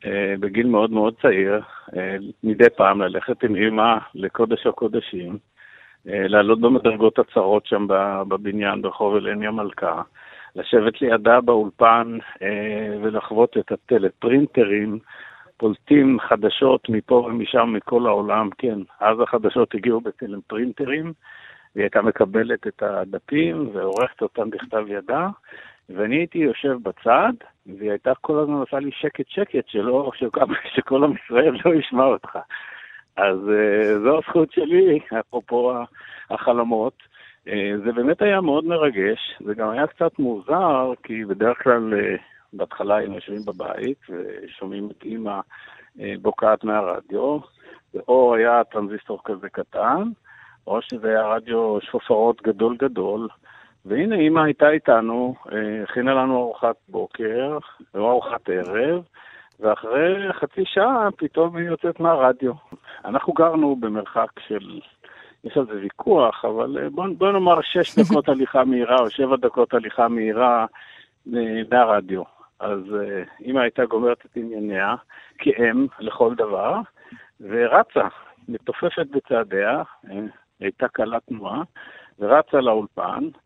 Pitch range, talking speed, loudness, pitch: 105-140 Hz, 120 wpm, -21 LUFS, 115 Hz